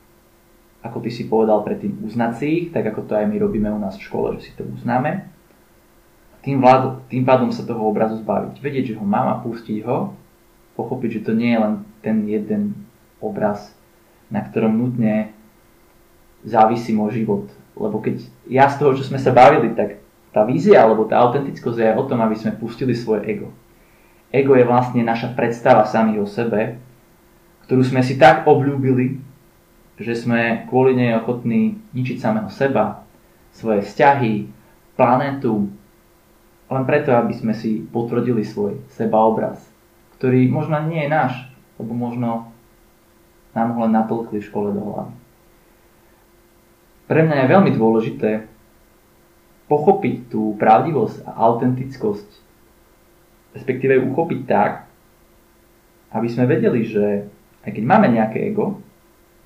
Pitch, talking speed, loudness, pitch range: 120 Hz, 145 wpm, -18 LUFS, 110-130 Hz